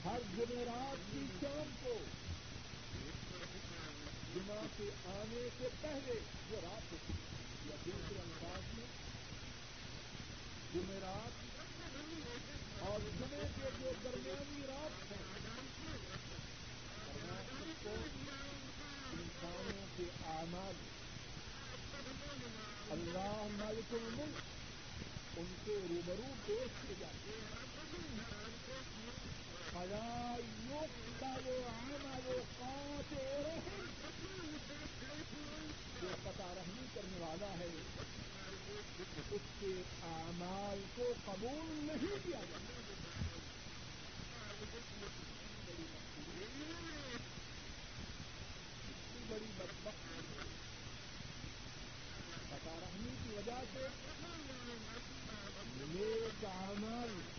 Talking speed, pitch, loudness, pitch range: 65 wpm, 210 Hz, -47 LUFS, 175-265 Hz